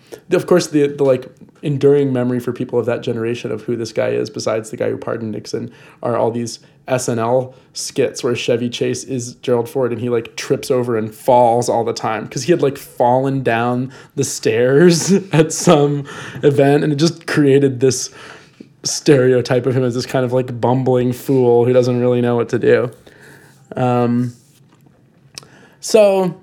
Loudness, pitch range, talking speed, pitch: -16 LUFS, 120-145 Hz, 180 wpm, 130 Hz